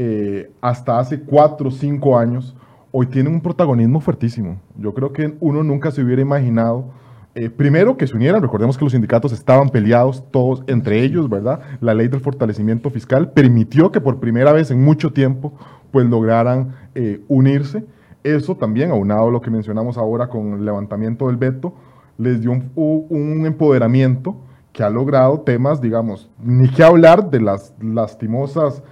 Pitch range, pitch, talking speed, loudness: 115-145 Hz, 130 Hz, 170 wpm, -16 LUFS